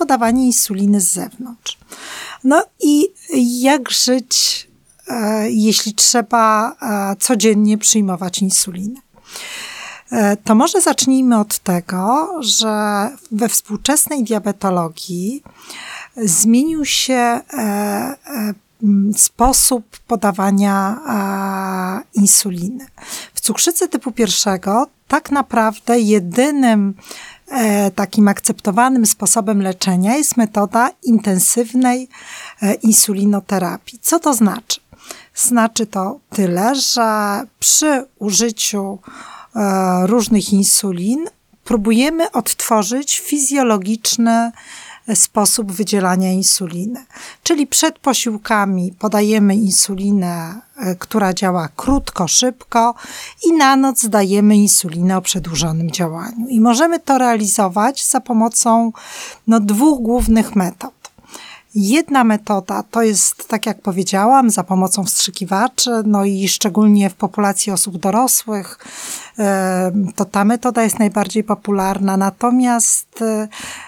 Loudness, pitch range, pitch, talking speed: -15 LUFS, 200-250 Hz, 220 Hz, 90 wpm